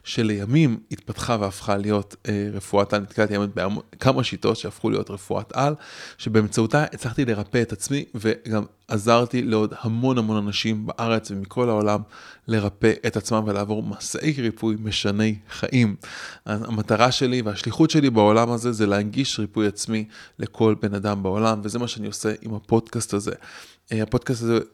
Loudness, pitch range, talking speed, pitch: -23 LUFS, 105-120 Hz, 145 wpm, 110 Hz